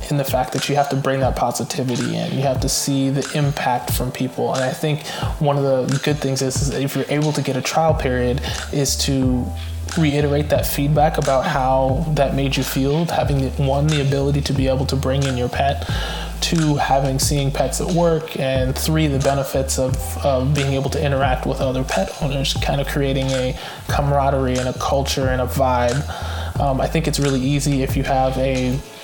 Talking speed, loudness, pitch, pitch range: 210 wpm, -19 LUFS, 135 Hz, 130-145 Hz